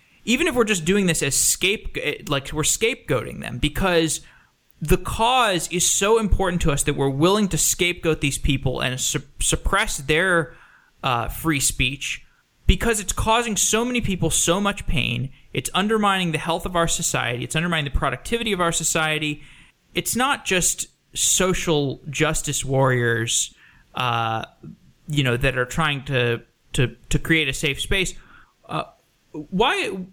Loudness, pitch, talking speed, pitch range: -21 LUFS, 160 Hz, 155 wpm, 135-185 Hz